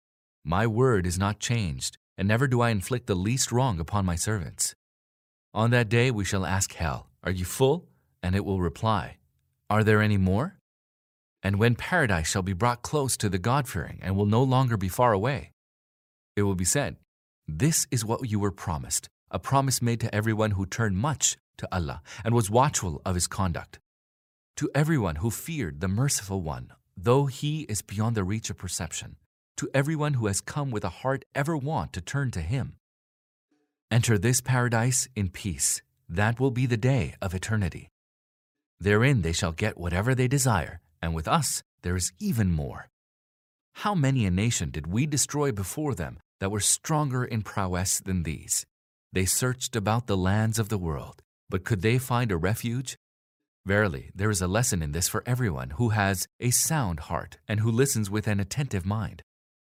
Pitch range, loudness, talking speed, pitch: 95-125 Hz, -27 LUFS, 185 wpm, 105 Hz